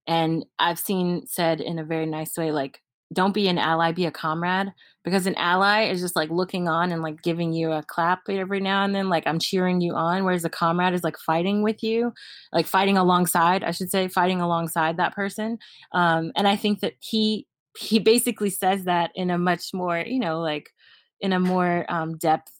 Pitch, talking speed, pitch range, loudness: 180 Hz, 210 wpm, 165-195 Hz, -23 LUFS